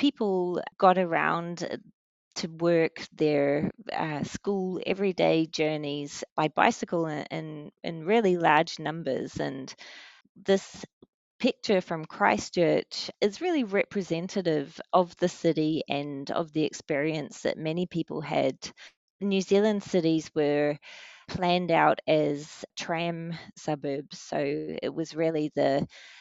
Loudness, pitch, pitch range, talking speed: -28 LUFS, 170 Hz, 155-195 Hz, 115 wpm